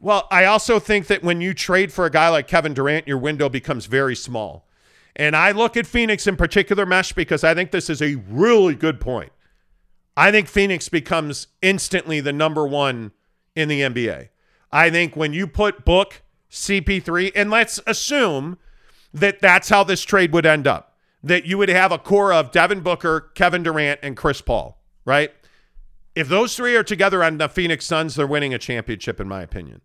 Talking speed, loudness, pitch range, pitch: 195 wpm, -18 LUFS, 145-195 Hz, 165 Hz